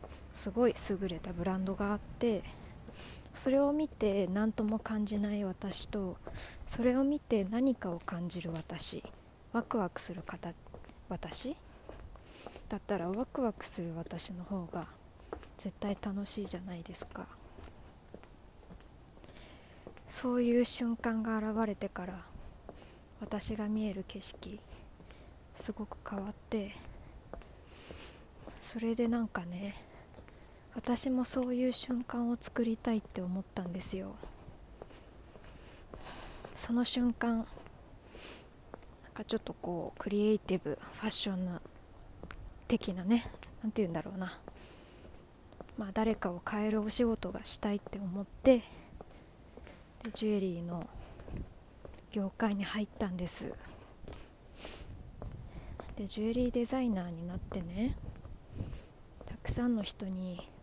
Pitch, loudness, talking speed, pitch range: 210 Hz, -36 LUFS, 225 characters per minute, 185-230 Hz